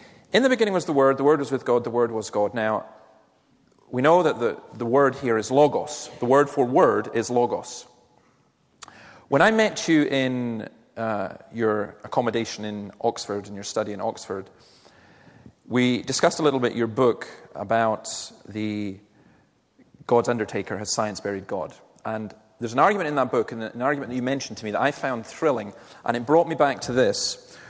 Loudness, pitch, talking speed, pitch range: -24 LUFS, 120 Hz, 185 wpm, 110-140 Hz